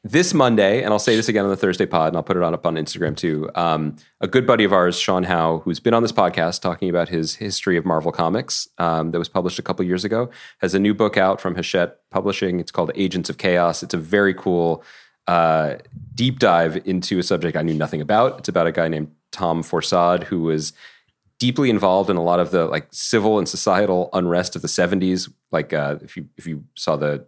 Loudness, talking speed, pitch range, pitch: -20 LUFS, 235 wpm, 80-100 Hz, 90 Hz